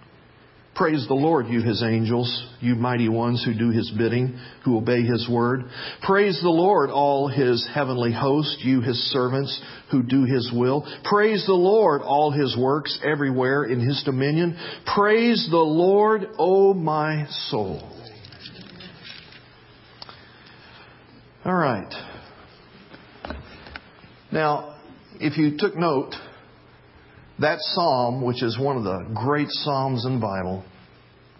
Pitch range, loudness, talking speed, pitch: 120-150 Hz, -22 LUFS, 130 wpm, 130 Hz